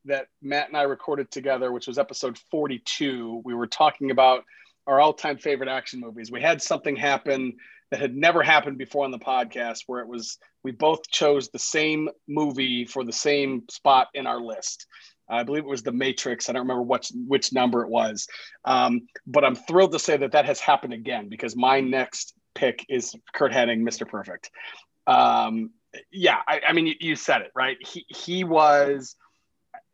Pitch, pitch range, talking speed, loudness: 135 Hz, 125-155 Hz, 190 wpm, -24 LUFS